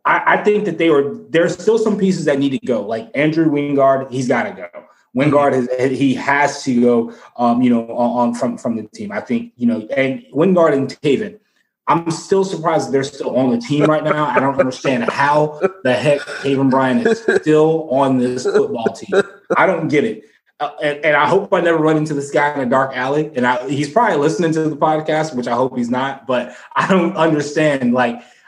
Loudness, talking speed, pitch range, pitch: -16 LUFS, 225 wpm, 130-160 Hz, 145 Hz